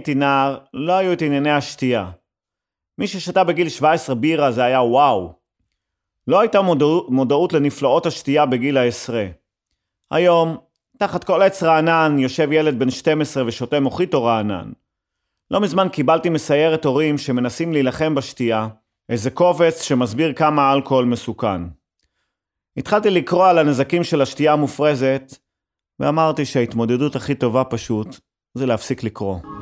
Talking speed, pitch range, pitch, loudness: 130 wpm, 120-160 Hz, 140 Hz, -18 LUFS